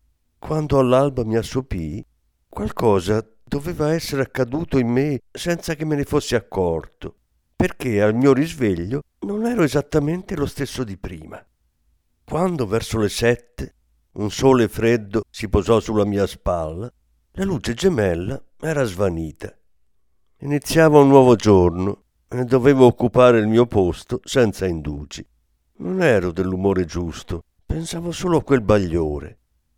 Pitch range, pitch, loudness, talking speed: 85-140 Hz, 115 Hz, -20 LUFS, 130 wpm